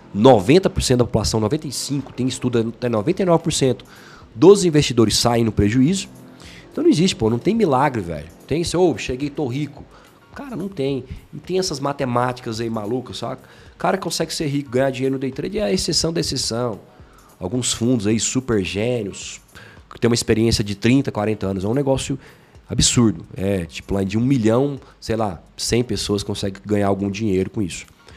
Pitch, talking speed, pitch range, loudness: 120 Hz, 180 wpm, 105-140 Hz, -20 LUFS